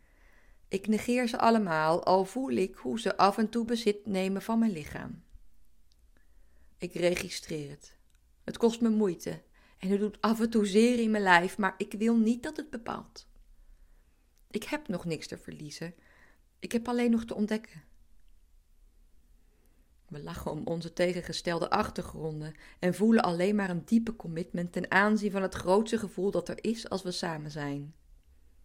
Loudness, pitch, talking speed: -30 LUFS, 180 Hz, 165 wpm